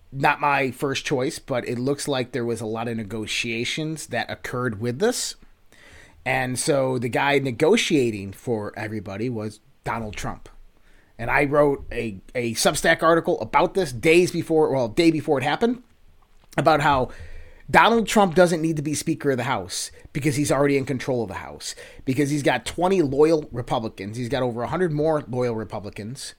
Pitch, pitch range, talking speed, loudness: 135 Hz, 115-155 Hz, 175 wpm, -23 LUFS